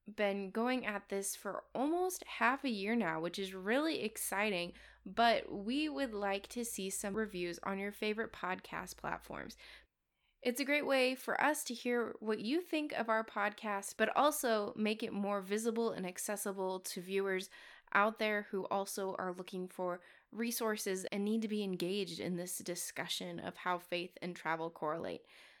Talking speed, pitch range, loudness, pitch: 170 wpm, 190-235 Hz, -37 LUFS, 210 Hz